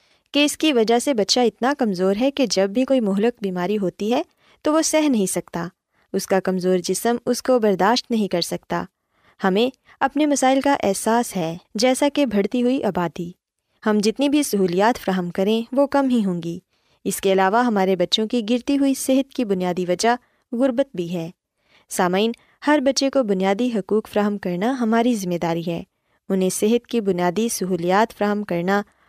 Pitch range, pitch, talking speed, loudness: 190-255 Hz, 220 Hz, 180 wpm, -20 LUFS